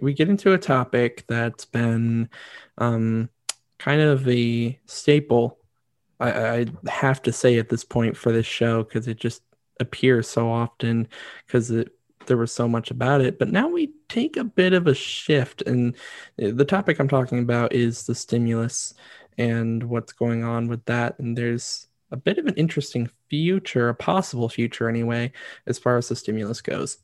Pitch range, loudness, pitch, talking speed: 115-135 Hz, -23 LUFS, 120 Hz, 175 wpm